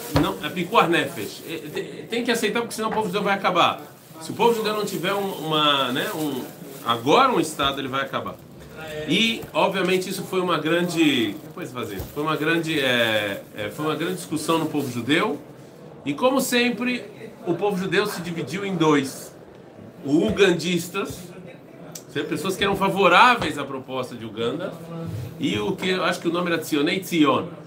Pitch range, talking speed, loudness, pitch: 150-195 Hz, 165 wpm, -22 LUFS, 170 Hz